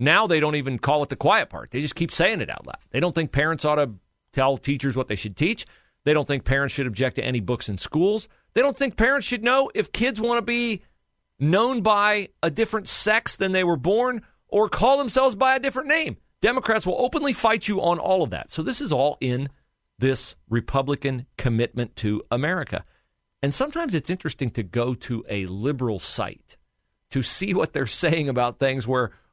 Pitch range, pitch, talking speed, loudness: 130-215 Hz, 150 Hz, 210 wpm, -23 LUFS